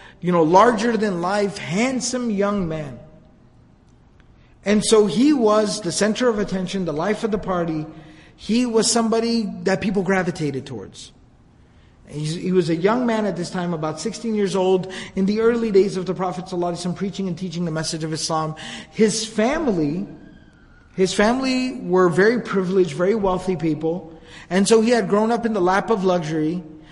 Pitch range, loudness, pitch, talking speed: 170-215 Hz, -20 LUFS, 190 Hz, 170 wpm